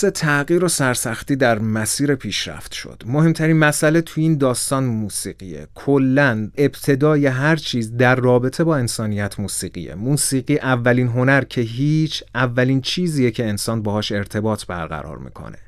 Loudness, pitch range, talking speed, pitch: -18 LUFS, 110-145 Hz, 135 wpm, 130 Hz